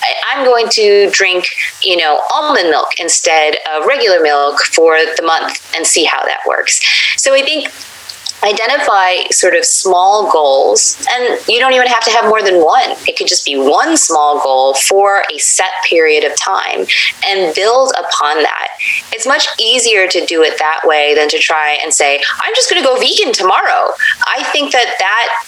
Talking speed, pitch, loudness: 185 wpm, 230 Hz, -10 LUFS